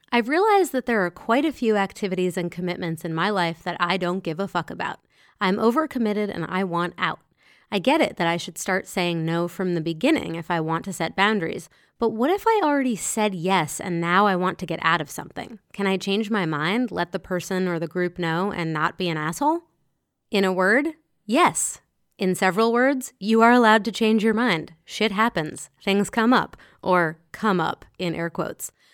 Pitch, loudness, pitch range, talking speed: 190 Hz, -23 LUFS, 175-225 Hz, 215 wpm